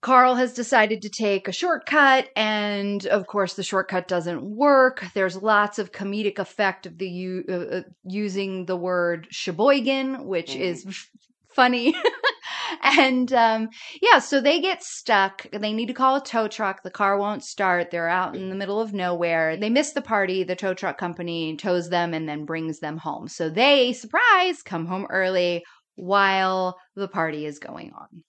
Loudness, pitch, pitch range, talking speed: -22 LUFS, 195 Hz, 180-245 Hz, 175 wpm